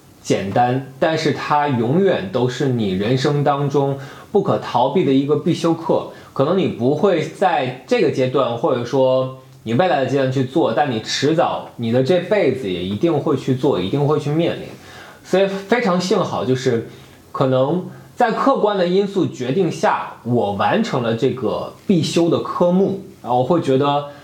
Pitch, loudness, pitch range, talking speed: 145 Hz, -18 LUFS, 130-175 Hz, 250 characters per minute